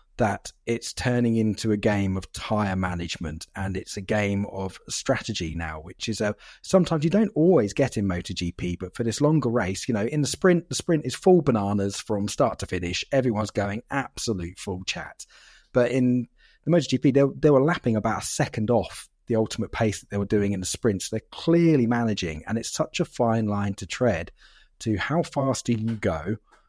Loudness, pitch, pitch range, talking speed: -25 LUFS, 110 Hz, 100-130 Hz, 200 wpm